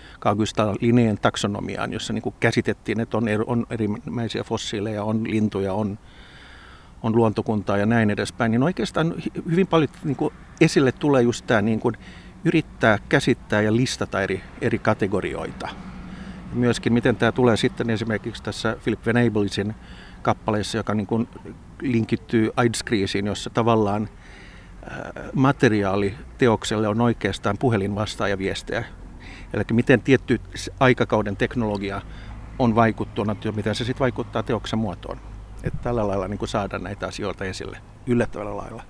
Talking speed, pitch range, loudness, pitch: 110 wpm, 100-120 Hz, -23 LUFS, 110 Hz